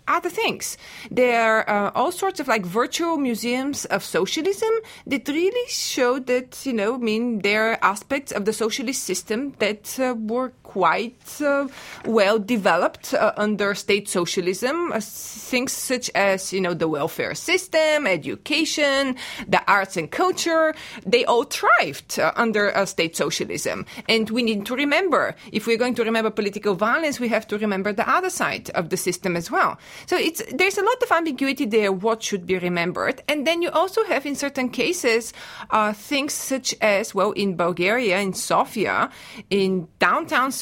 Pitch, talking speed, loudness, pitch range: 240 Hz, 170 wpm, -22 LUFS, 210-290 Hz